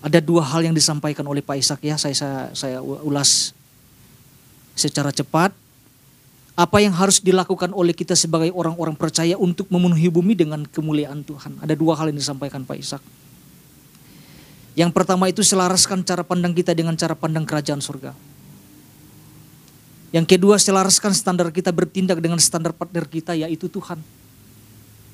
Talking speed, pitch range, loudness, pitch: 145 wpm, 145-180 Hz, -19 LUFS, 160 Hz